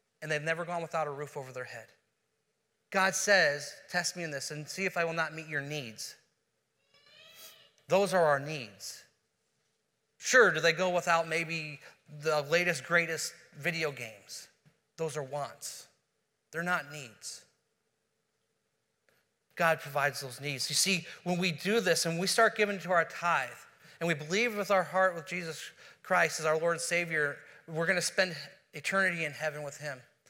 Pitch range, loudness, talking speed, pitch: 150-175 Hz, -30 LUFS, 170 wpm, 165 Hz